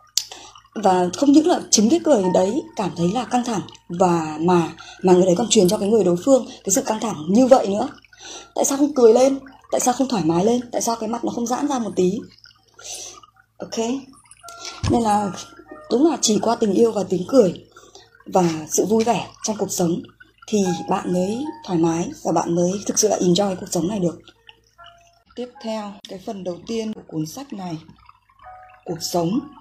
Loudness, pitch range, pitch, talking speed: -20 LUFS, 180-265 Hz, 220 Hz, 205 wpm